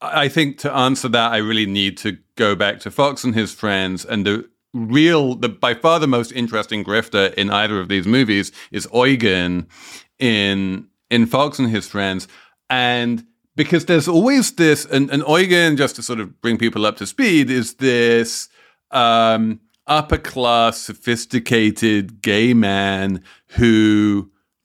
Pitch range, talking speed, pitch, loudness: 105-130 Hz, 160 wpm, 115 Hz, -17 LUFS